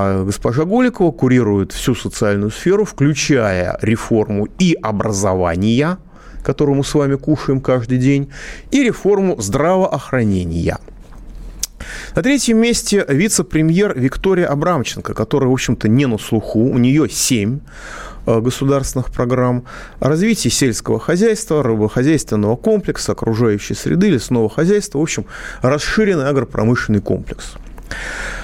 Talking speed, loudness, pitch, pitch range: 110 wpm, -16 LUFS, 130 Hz, 110-165 Hz